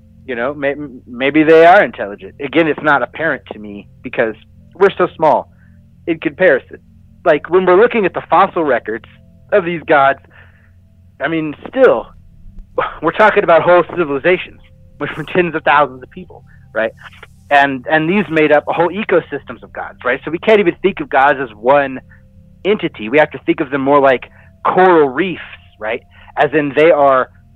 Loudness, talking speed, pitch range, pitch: -13 LUFS, 175 wpm, 110-170 Hz, 145 Hz